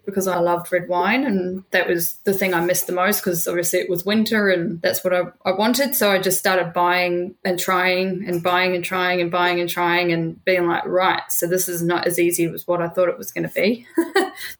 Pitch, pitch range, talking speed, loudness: 180 Hz, 175-190 Hz, 245 wpm, -20 LUFS